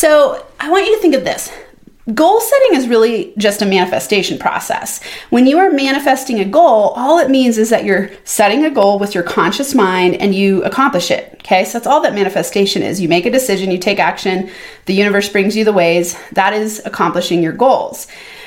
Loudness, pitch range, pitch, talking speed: -13 LUFS, 195-270 Hz, 210 Hz, 210 wpm